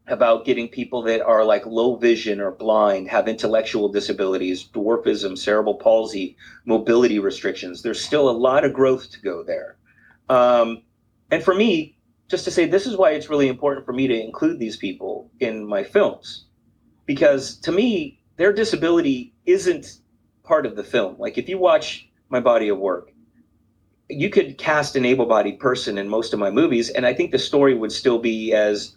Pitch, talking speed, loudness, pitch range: 125 Hz, 180 wpm, -20 LUFS, 110-155 Hz